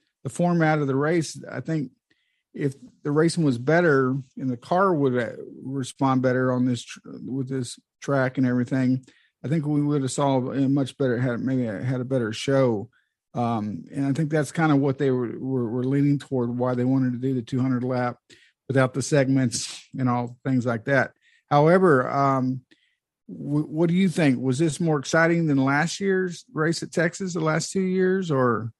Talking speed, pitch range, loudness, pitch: 195 wpm, 130-155 Hz, -24 LUFS, 135 Hz